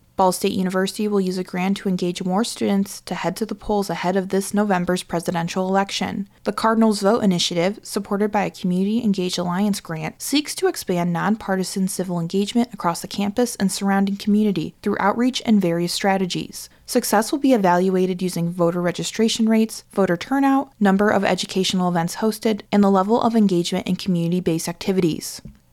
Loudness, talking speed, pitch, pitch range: -21 LUFS, 175 wpm, 195 Hz, 180-210 Hz